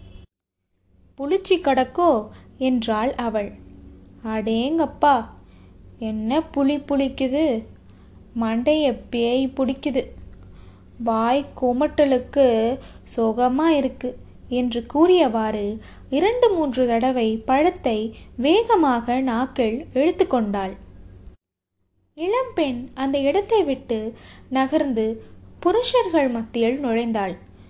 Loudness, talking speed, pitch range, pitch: -21 LUFS, 65 wpm, 220-285 Hz, 250 Hz